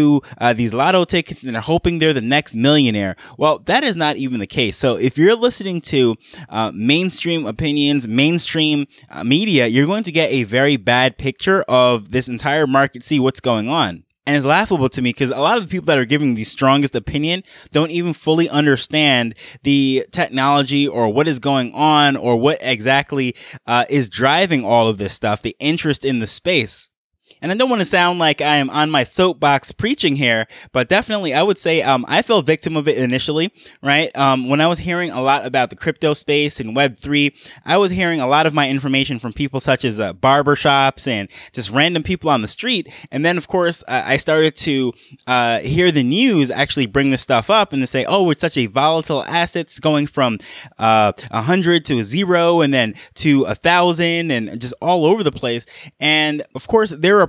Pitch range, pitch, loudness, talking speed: 130-165 Hz, 145 Hz, -16 LUFS, 210 wpm